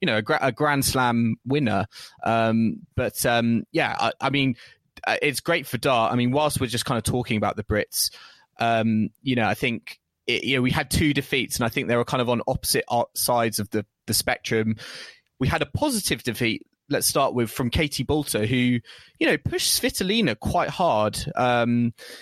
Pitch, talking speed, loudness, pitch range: 125 Hz, 195 wpm, -23 LUFS, 115-140 Hz